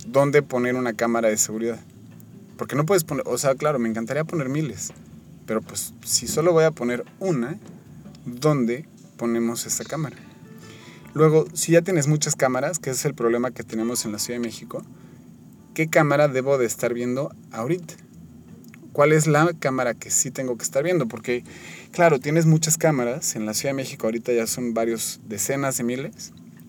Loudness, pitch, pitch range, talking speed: -23 LUFS, 130 Hz, 115-155 Hz, 180 wpm